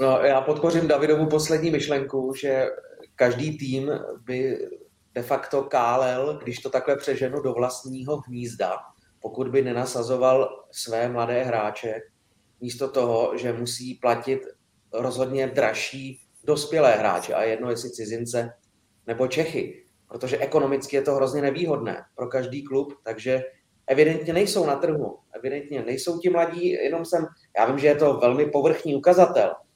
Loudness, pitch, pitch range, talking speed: -24 LUFS, 135 Hz, 120-150 Hz, 140 wpm